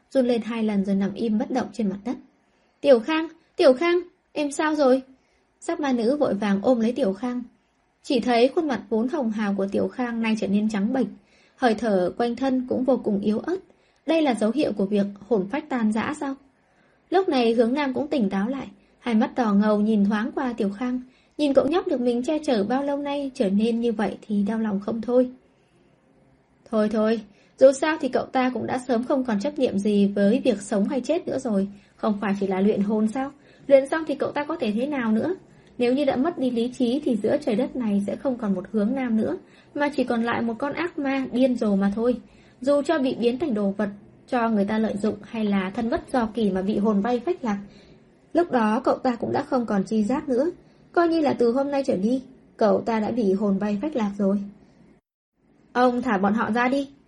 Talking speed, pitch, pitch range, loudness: 240 wpm, 245 Hz, 215-270 Hz, -24 LUFS